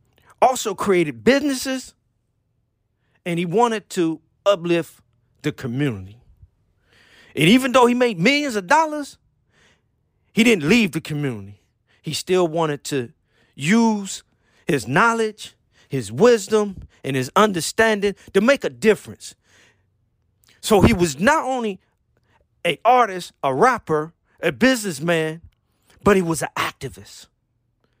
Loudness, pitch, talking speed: -19 LUFS, 160 Hz, 120 wpm